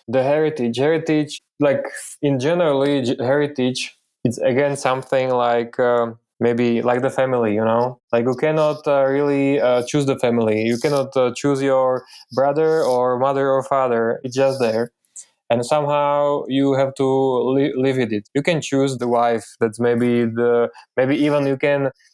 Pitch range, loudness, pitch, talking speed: 120-140 Hz, -19 LUFS, 130 Hz, 170 wpm